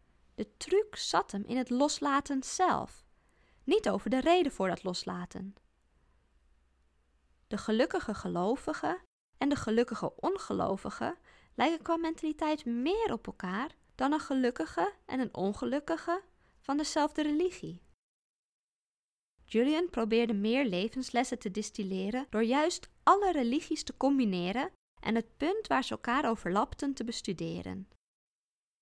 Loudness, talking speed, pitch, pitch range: -32 LUFS, 120 wpm, 255 Hz, 200-310 Hz